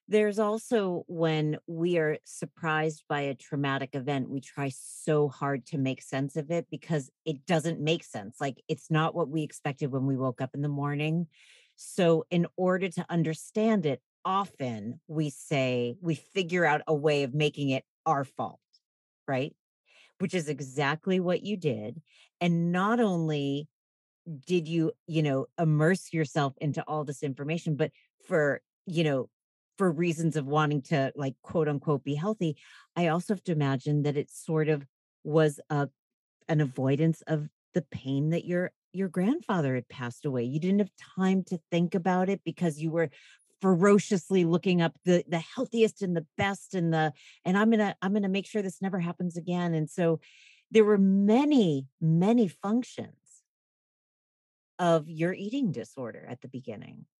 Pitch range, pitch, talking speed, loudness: 145-185 Hz, 160 Hz, 170 wpm, -29 LUFS